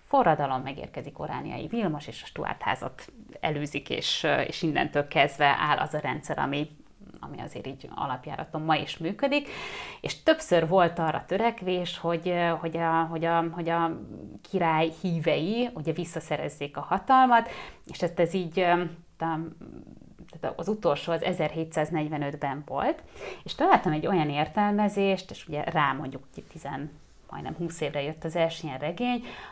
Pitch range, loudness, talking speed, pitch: 155-180 Hz, -28 LUFS, 145 wpm, 165 Hz